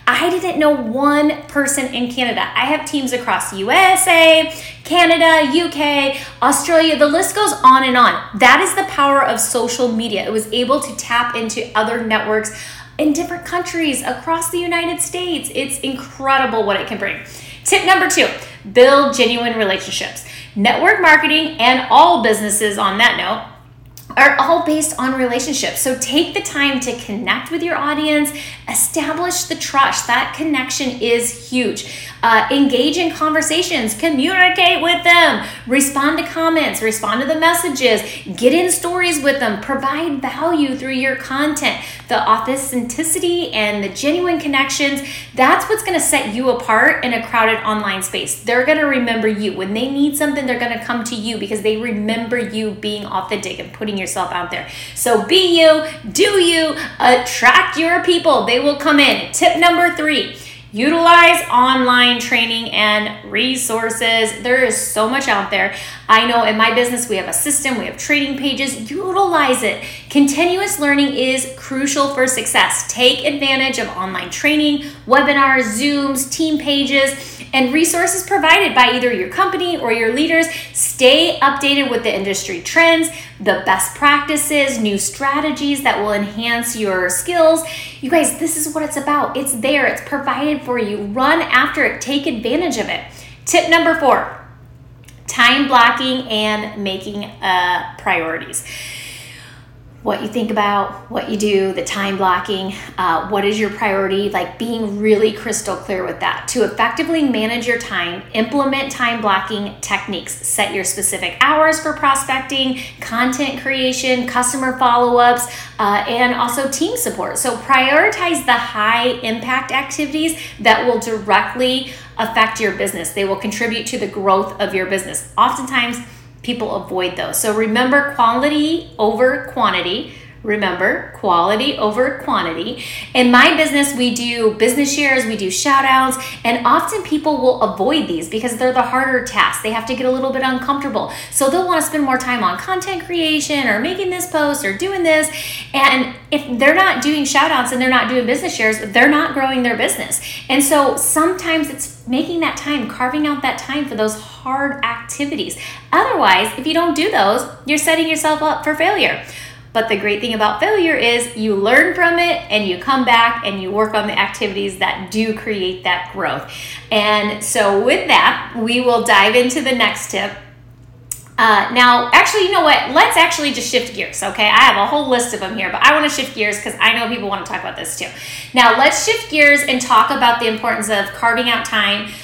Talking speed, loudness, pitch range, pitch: 170 wpm, -15 LUFS, 220-300 Hz, 255 Hz